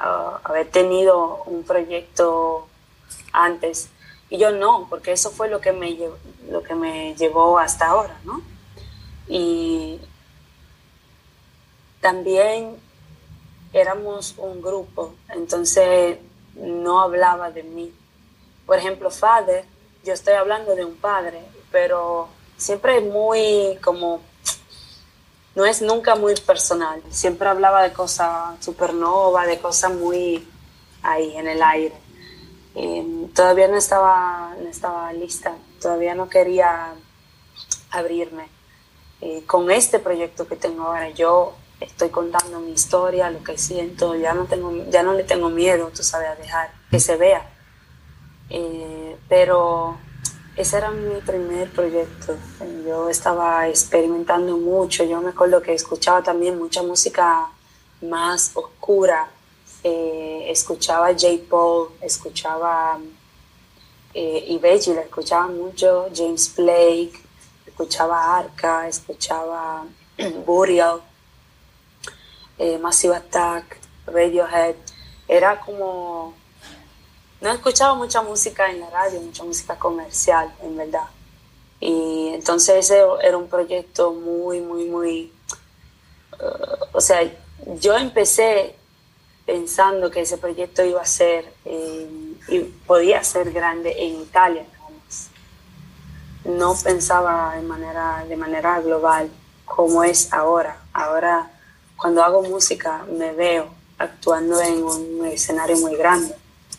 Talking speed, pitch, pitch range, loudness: 120 wpm, 170 Hz, 165-185 Hz, -19 LUFS